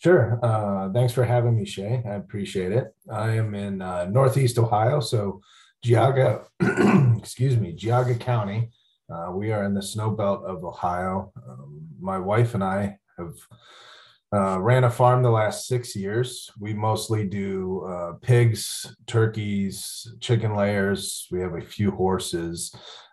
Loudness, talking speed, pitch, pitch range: -24 LUFS, 150 wpm, 110 Hz, 100-120 Hz